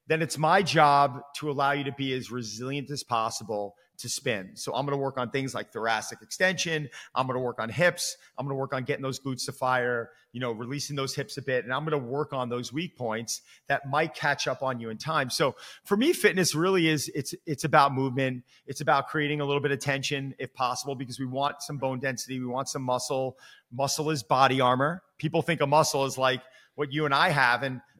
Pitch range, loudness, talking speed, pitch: 125-150 Hz, -28 LUFS, 240 wpm, 140 Hz